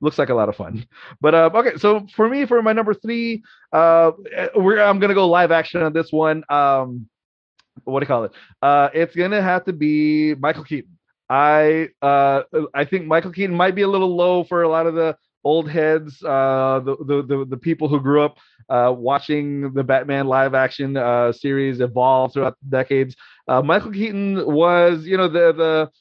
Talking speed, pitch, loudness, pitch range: 200 wpm, 155 Hz, -18 LUFS, 140-180 Hz